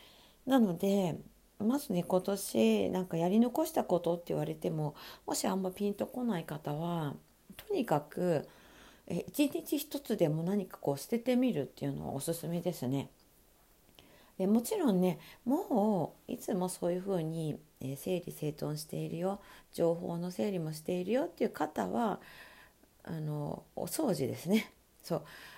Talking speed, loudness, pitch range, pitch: 290 characters per minute, -34 LUFS, 160-220 Hz, 180 Hz